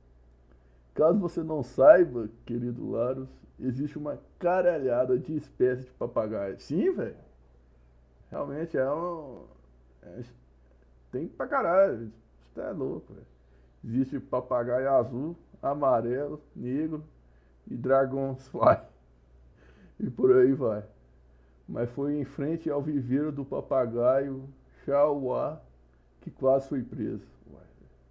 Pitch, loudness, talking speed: 125 Hz, -28 LUFS, 110 wpm